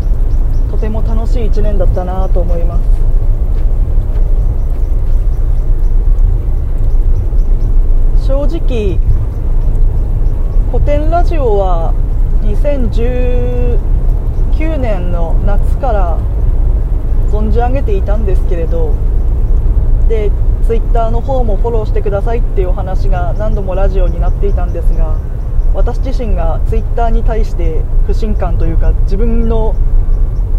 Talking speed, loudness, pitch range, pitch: 215 characters per minute, -15 LUFS, 95-110 Hz, 105 Hz